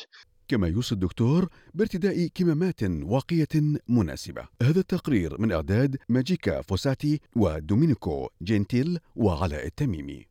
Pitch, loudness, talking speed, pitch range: 125 Hz, -26 LUFS, 100 wpm, 100-160 Hz